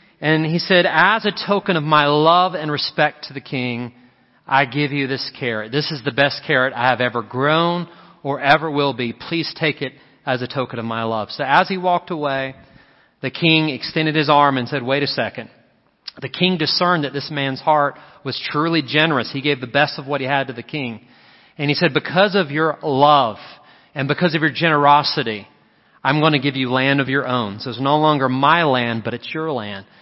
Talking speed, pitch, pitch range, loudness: 215 wpm, 145 Hz, 130-155 Hz, -18 LUFS